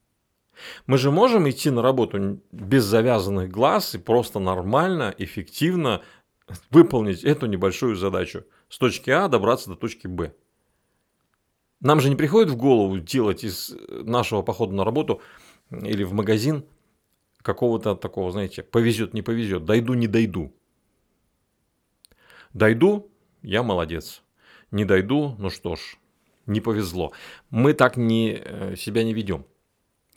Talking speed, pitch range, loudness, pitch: 125 wpm, 100-135 Hz, -22 LUFS, 115 Hz